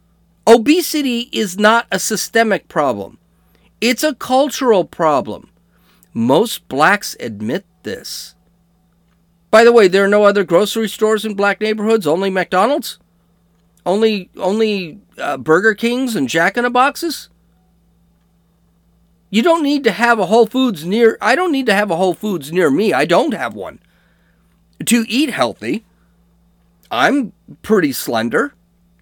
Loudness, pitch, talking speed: -15 LUFS, 200 Hz, 140 wpm